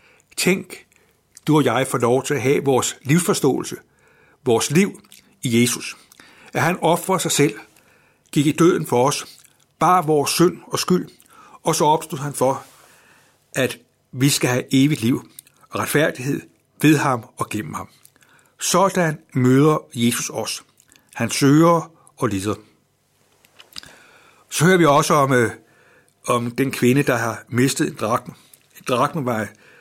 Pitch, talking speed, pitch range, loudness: 140 Hz, 145 wpm, 125-160 Hz, -19 LUFS